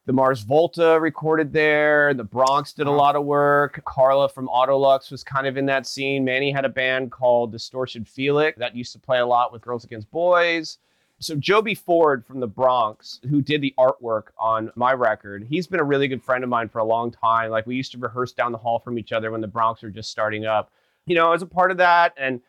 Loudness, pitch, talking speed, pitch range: -21 LUFS, 130 Hz, 240 wpm, 120-145 Hz